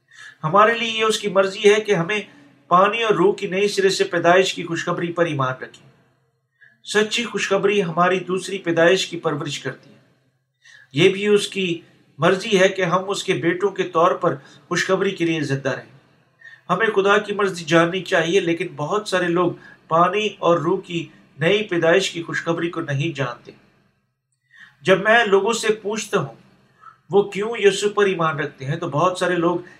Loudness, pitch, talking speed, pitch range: -19 LUFS, 180 Hz, 175 wpm, 165-200 Hz